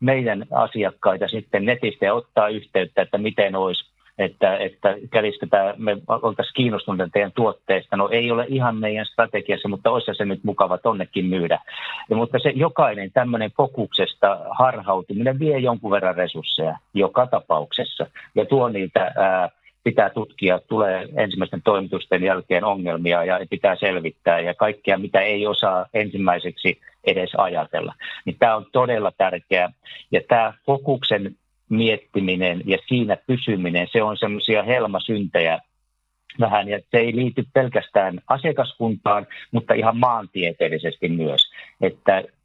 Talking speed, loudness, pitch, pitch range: 130 wpm, -21 LUFS, 105 Hz, 95-115 Hz